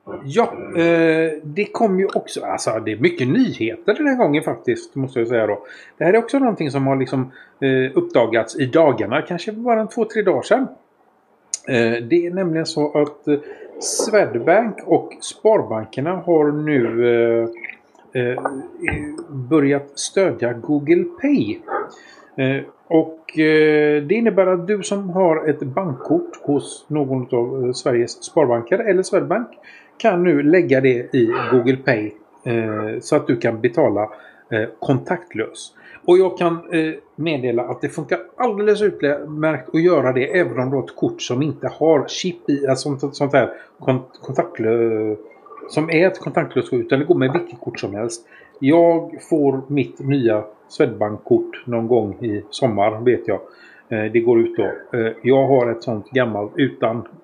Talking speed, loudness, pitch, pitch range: 150 wpm, -19 LUFS, 150 Hz, 125-190 Hz